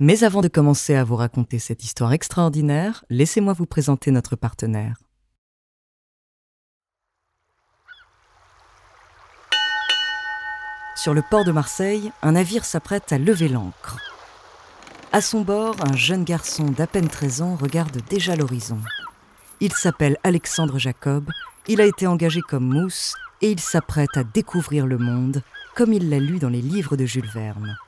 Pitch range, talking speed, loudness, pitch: 135-185 Hz, 140 wpm, -21 LUFS, 160 Hz